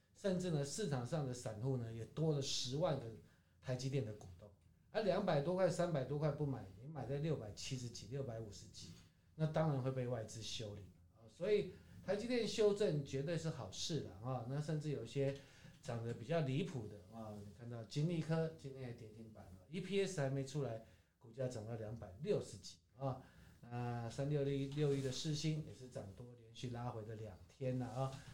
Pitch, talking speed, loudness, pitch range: 130 Hz, 295 characters per minute, -42 LUFS, 110-150 Hz